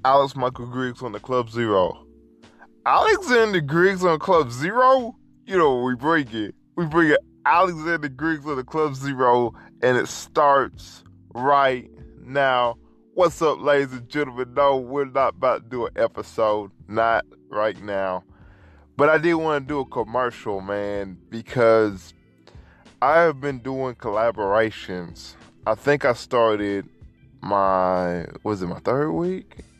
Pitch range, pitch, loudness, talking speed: 105-150 Hz, 125 Hz, -22 LUFS, 145 wpm